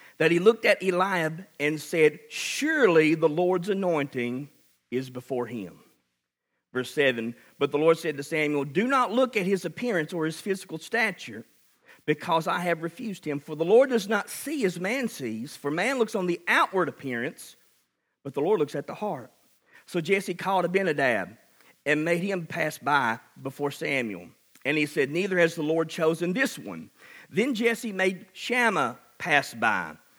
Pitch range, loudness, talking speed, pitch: 145-195 Hz, -26 LUFS, 175 wpm, 170 Hz